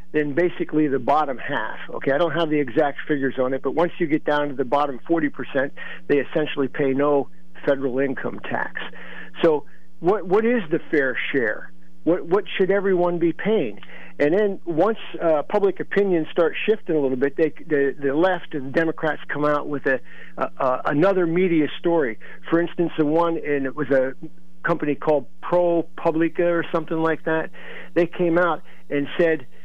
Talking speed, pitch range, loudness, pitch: 180 wpm, 140-170 Hz, -22 LUFS, 155 Hz